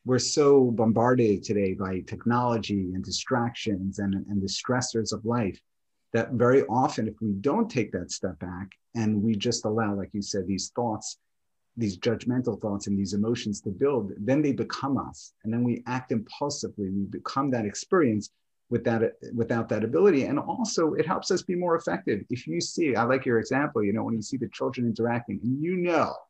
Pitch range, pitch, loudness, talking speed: 100-125 Hz, 115 Hz, -27 LUFS, 195 wpm